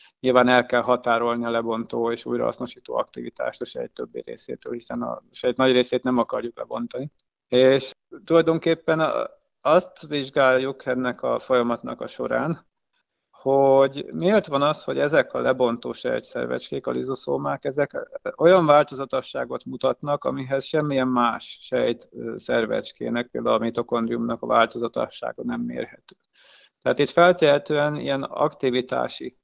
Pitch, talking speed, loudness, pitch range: 135 Hz, 125 wpm, -23 LUFS, 120-160 Hz